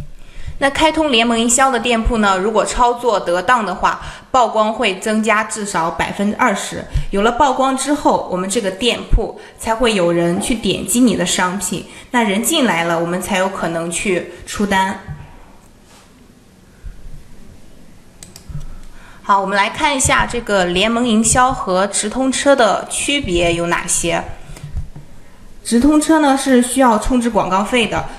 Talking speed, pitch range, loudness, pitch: 220 characters per minute, 185-250 Hz, -15 LUFS, 220 Hz